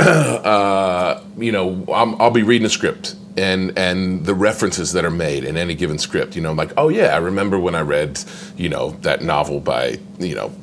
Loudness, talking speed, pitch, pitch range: -18 LUFS, 215 wpm, 100 Hz, 95-110 Hz